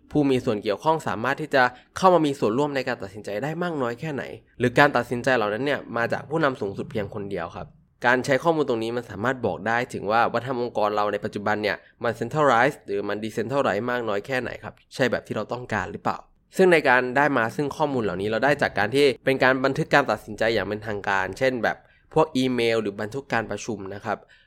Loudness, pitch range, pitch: -24 LUFS, 105-140 Hz, 125 Hz